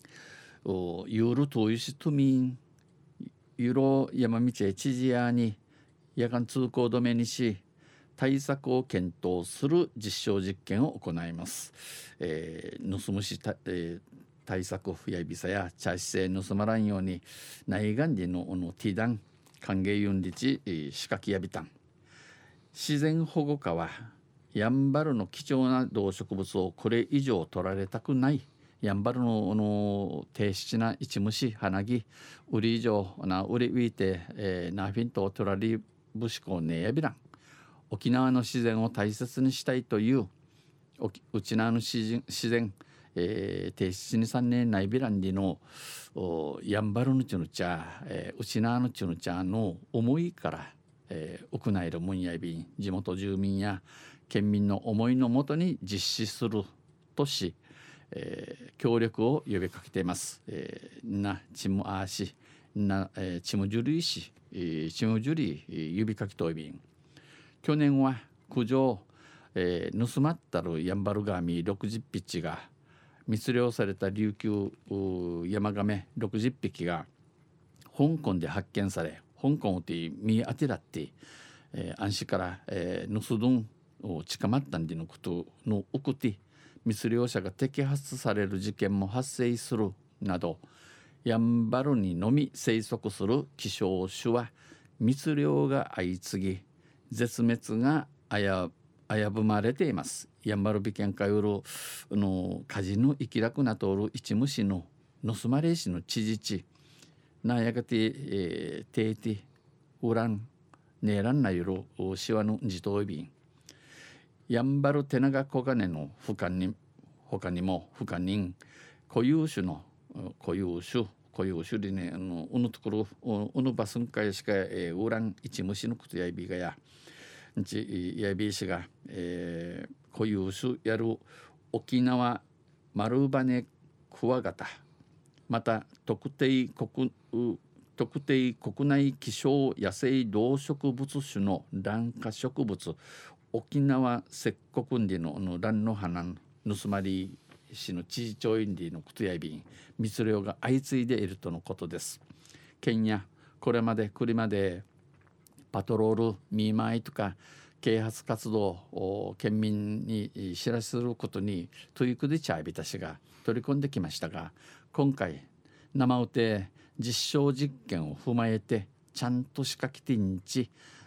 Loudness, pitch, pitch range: -31 LUFS, 110 Hz, 95-130 Hz